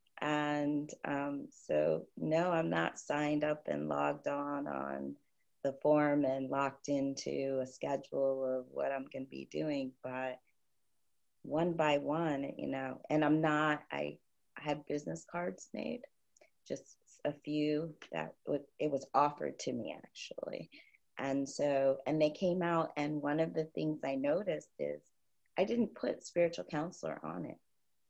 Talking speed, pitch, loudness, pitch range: 155 wpm, 145 Hz, -36 LUFS, 130-150 Hz